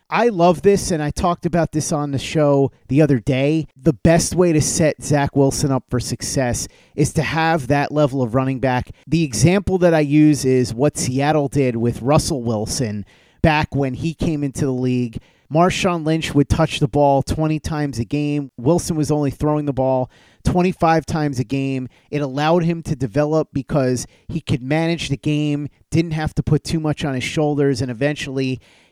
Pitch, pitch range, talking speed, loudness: 145 Hz, 135-160 Hz, 195 wpm, -19 LUFS